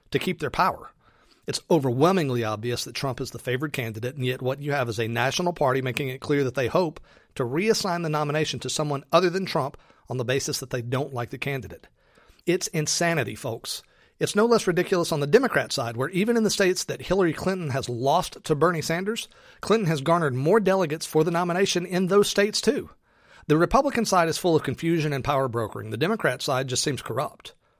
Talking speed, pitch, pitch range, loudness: 210 wpm, 150 Hz, 130-180 Hz, -25 LUFS